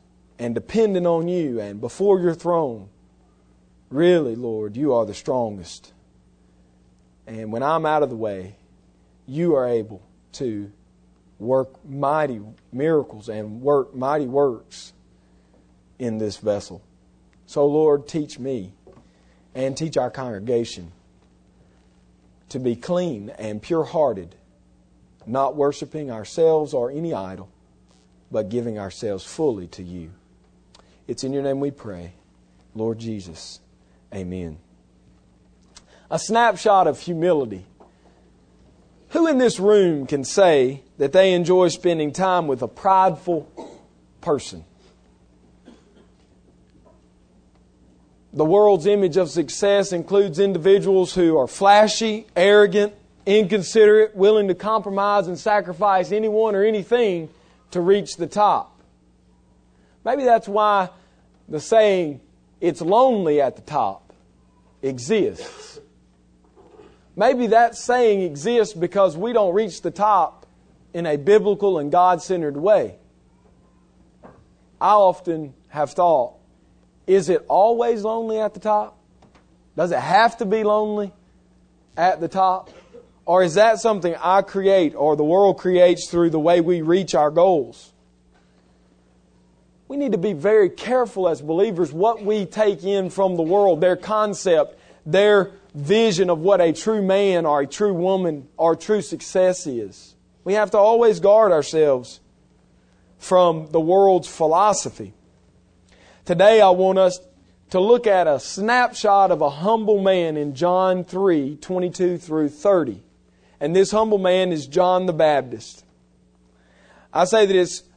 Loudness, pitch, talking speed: -19 LUFS, 155 Hz, 125 wpm